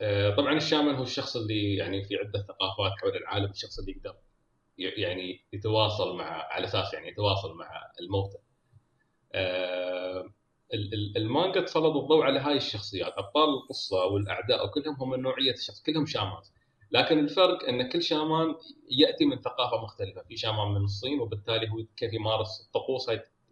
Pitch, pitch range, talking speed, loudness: 115 Hz, 100-150 Hz, 150 wpm, -29 LUFS